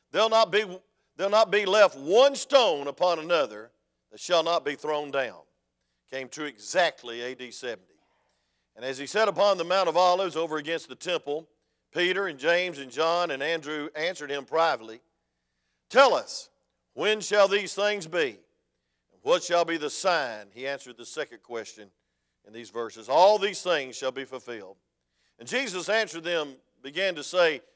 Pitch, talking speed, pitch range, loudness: 160 Hz, 165 wpm, 125-190 Hz, -26 LUFS